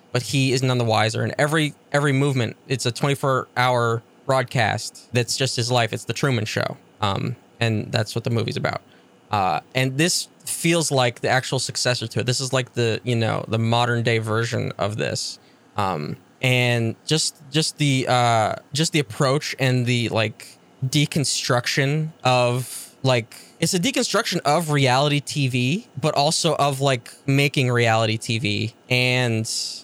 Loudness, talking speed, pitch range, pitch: -21 LUFS, 155 wpm, 120-145 Hz, 125 Hz